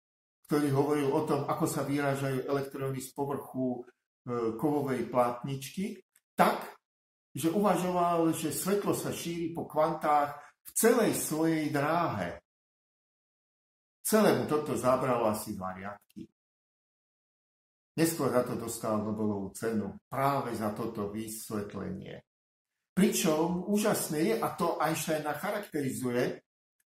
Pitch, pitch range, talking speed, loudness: 140 Hz, 115-160 Hz, 105 wpm, -31 LUFS